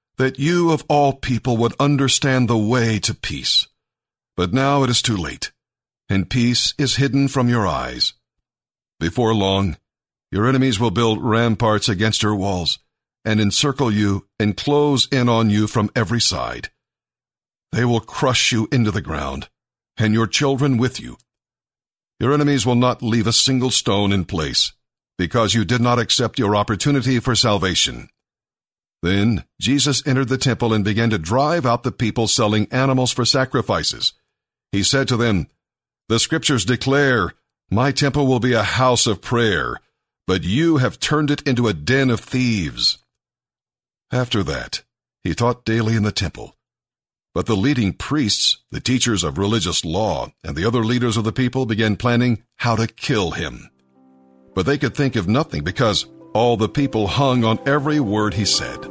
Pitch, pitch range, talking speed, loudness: 115 Hz, 105-130 Hz, 165 wpm, -18 LUFS